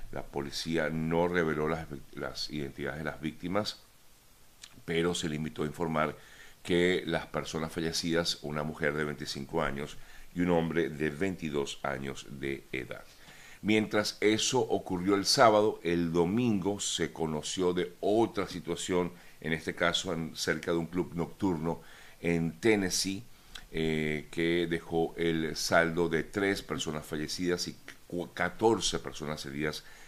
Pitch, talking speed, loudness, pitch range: 85 Hz, 140 wpm, -31 LUFS, 75-90 Hz